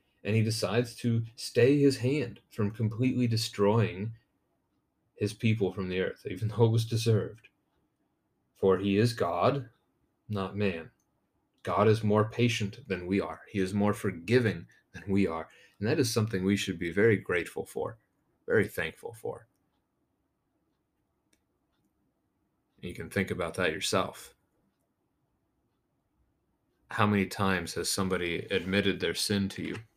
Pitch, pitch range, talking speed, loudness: 105 Hz, 95-115 Hz, 140 wpm, -29 LUFS